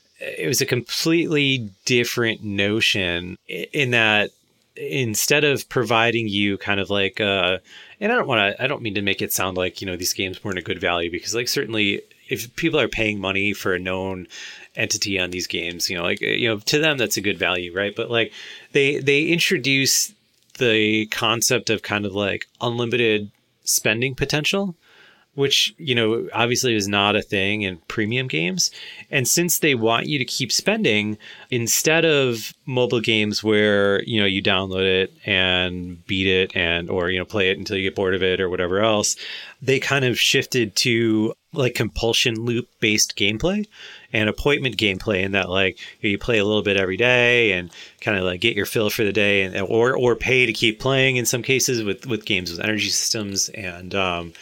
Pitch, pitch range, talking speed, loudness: 110 Hz, 95-125 Hz, 195 wpm, -20 LUFS